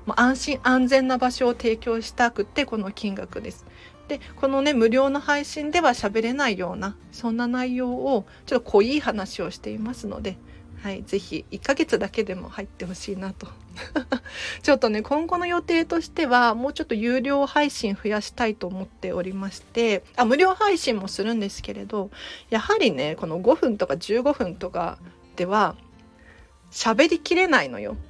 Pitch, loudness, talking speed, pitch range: 235 Hz, -24 LUFS, 320 characters per minute, 200-275 Hz